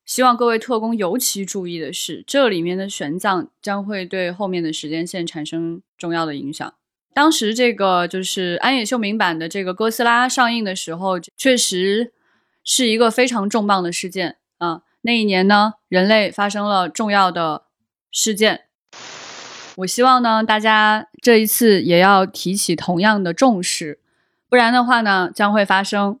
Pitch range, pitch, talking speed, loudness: 180-230 Hz, 200 Hz, 255 characters per minute, -17 LUFS